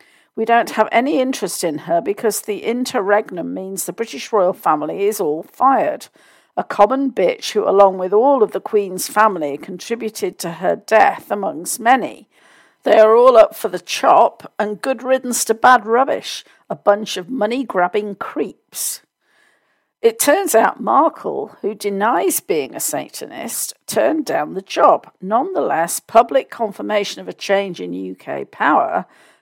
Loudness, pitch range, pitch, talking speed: -17 LUFS, 195-255 Hz, 215 Hz, 155 wpm